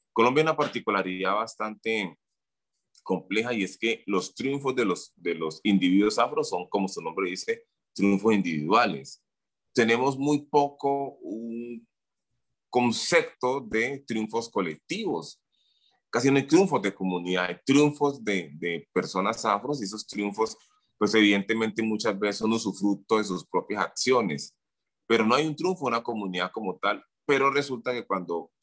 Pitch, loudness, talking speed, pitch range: 115 Hz, -26 LUFS, 150 wpm, 100-140 Hz